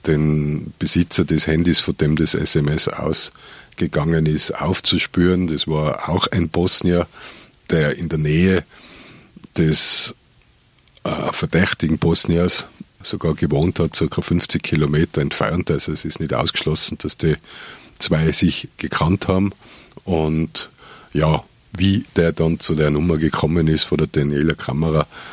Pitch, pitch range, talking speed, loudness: 80 Hz, 75-85 Hz, 135 wpm, -18 LUFS